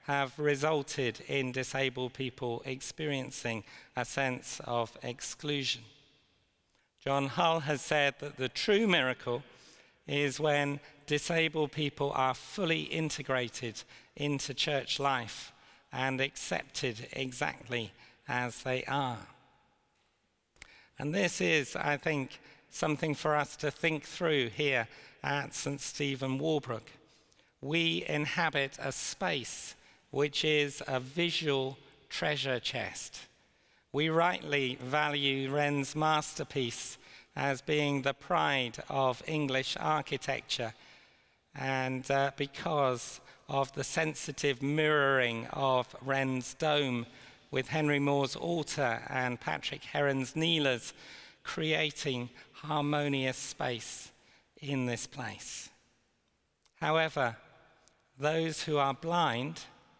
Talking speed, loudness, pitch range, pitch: 100 wpm, -32 LUFS, 130-150 Hz, 140 Hz